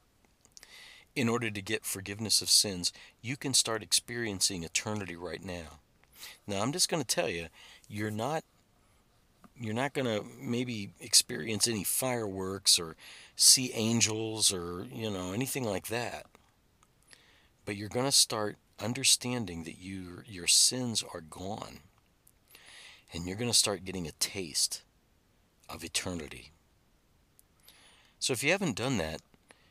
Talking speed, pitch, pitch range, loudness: 130 wpm, 105 Hz, 95-120 Hz, -29 LUFS